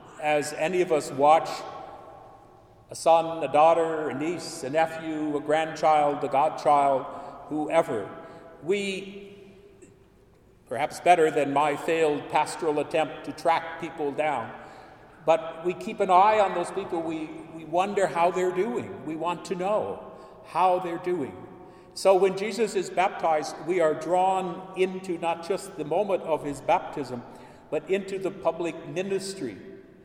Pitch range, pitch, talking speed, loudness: 155-185 Hz, 165 Hz, 145 wpm, -26 LUFS